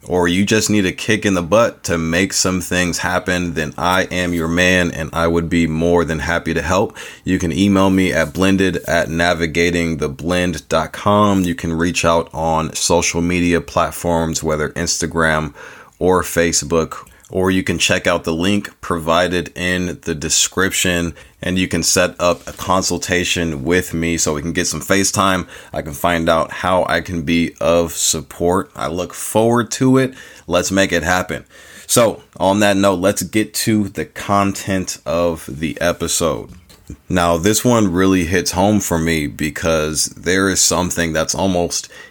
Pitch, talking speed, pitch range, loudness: 85 Hz, 170 wpm, 85-95 Hz, -16 LUFS